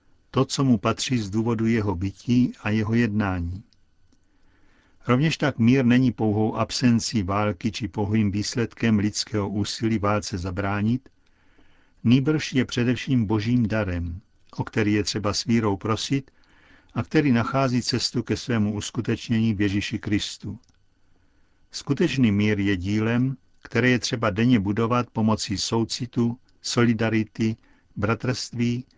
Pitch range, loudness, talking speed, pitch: 105-120 Hz, -24 LUFS, 125 wpm, 110 Hz